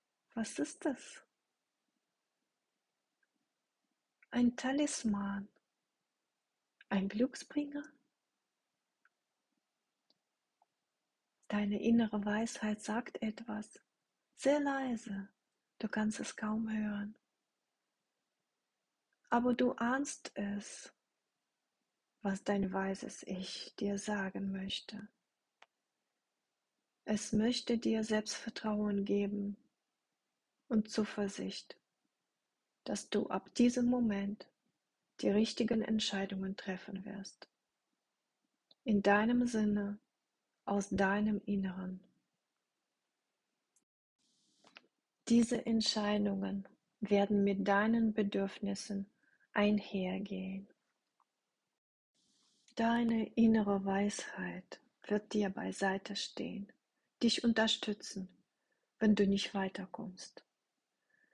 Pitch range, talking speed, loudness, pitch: 200-235 Hz, 70 wpm, -36 LUFS, 210 Hz